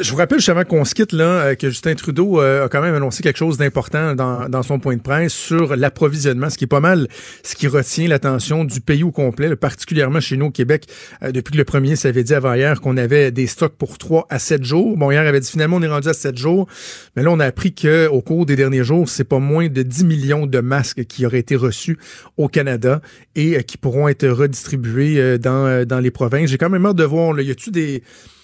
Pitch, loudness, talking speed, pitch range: 145 Hz, -16 LUFS, 255 wpm, 130-160 Hz